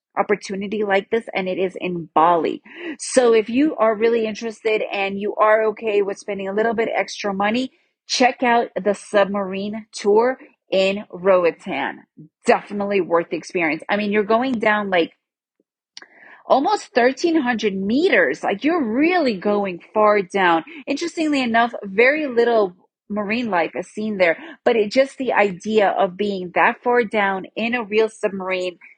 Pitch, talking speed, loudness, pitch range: 215 Hz, 155 wpm, -20 LUFS, 195-245 Hz